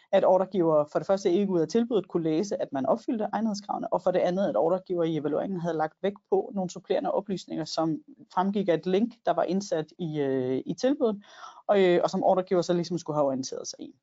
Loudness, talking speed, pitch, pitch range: -27 LUFS, 230 wpm, 185 Hz, 165-200 Hz